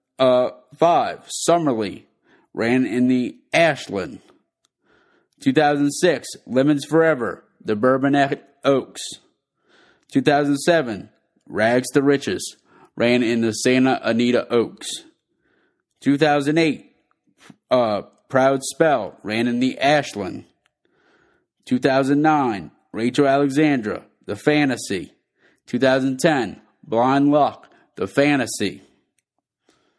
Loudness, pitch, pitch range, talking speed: -20 LUFS, 135 Hz, 125-145 Hz, 100 wpm